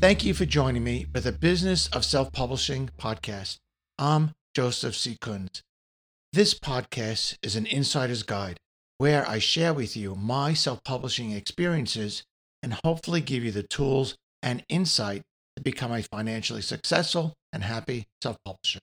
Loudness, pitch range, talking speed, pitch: -27 LUFS, 110-145 Hz, 155 wpm, 125 Hz